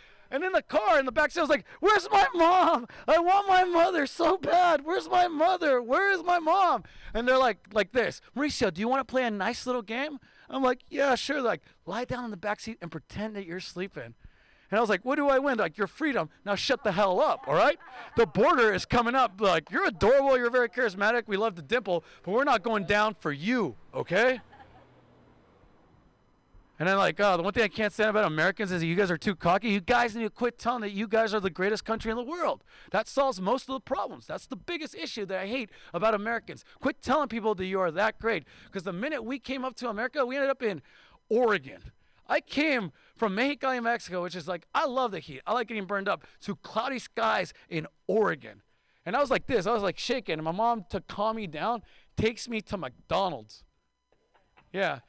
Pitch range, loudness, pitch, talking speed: 200-270 Hz, -28 LUFS, 230 Hz, 235 wpm